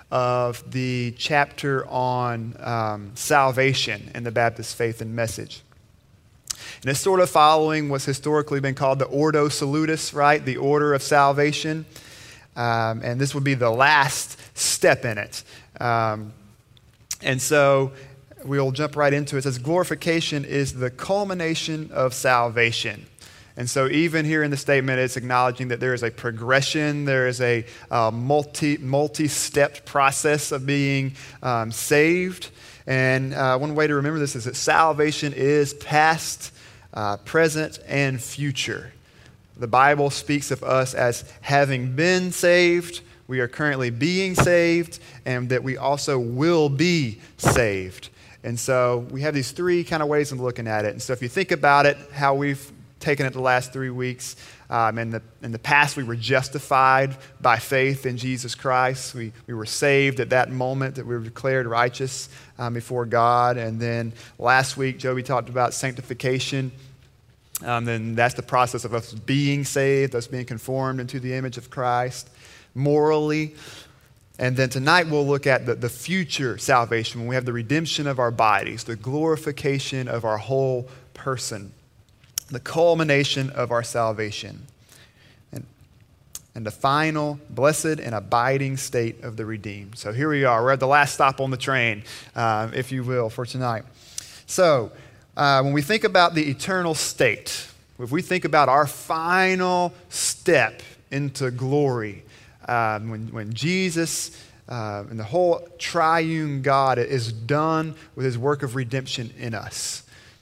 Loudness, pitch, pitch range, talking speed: -22 LUFS, 130 Hz, 120-145 Hz, 160 wpm